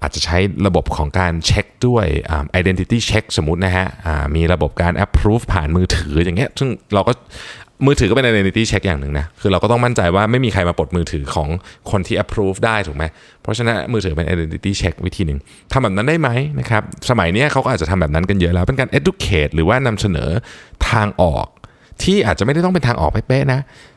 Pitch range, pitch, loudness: 85-115 Hz, 95 Hz, -17 LUFS